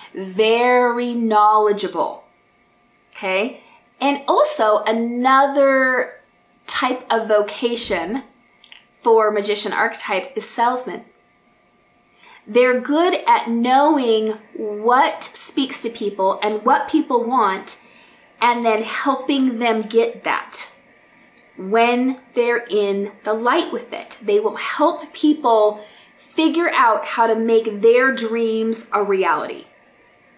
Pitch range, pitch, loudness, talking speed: 215-265 Hz, 235 Hz, -18 LUFS, 105 wpm